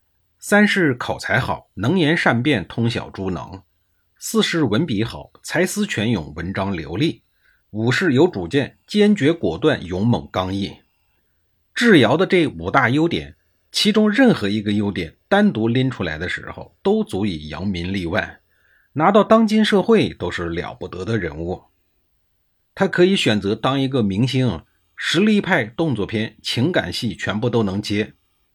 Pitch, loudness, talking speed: 110 Hz, -19 LUFS, 225 characters per minute